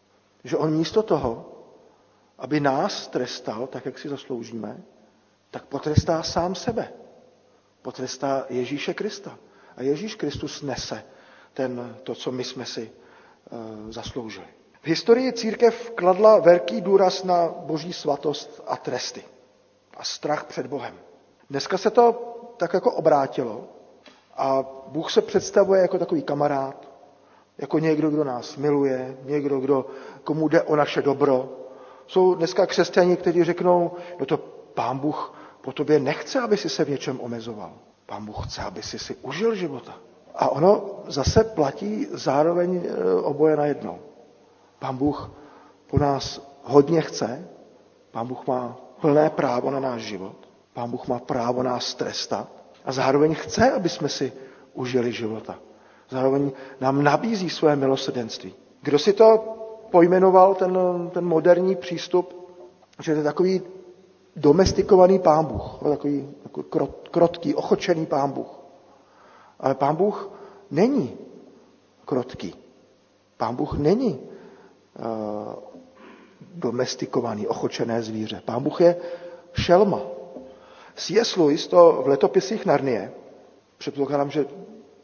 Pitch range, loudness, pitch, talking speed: 130-180 Hz, -23 LUFS, 150 Hz, 130 wpm